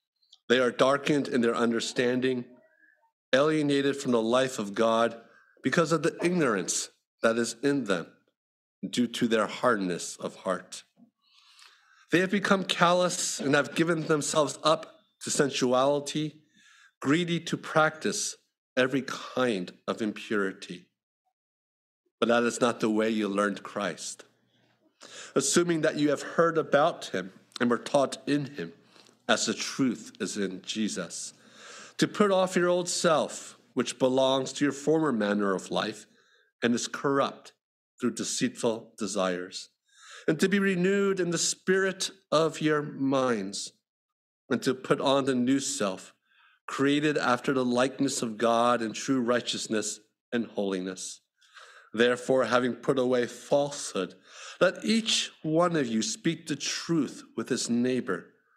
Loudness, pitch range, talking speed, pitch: -28 LUFS, 115-165 Hz, 140 wpm, 135 Hz